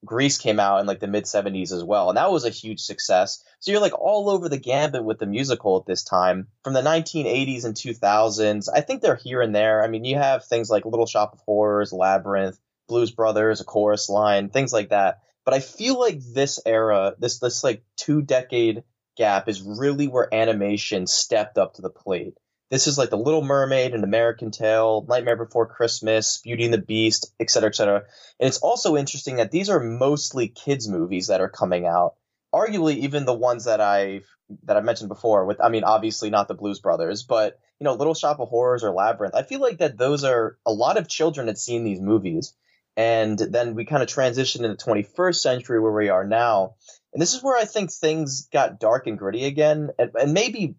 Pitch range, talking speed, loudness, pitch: 105-140 Hz, 220 wpm, -22 LUFS, 115 Hz